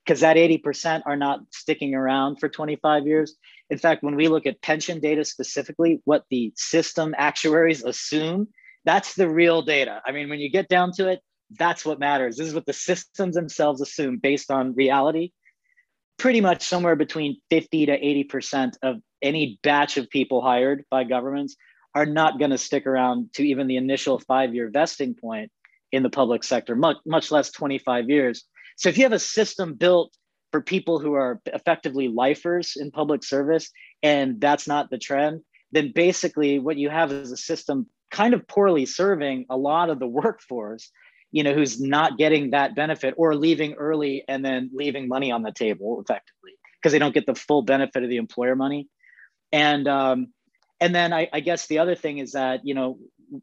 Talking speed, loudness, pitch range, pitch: 185 wpm, -23 LUFS, 135-165 Hz, 150 Hz